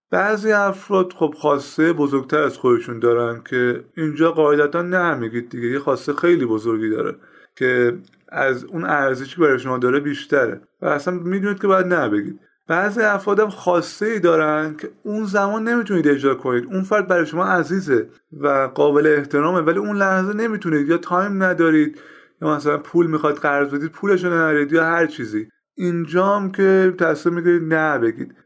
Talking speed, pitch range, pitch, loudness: 160 wpm, 145-190 Hz, 165 Hz, -19 LUFS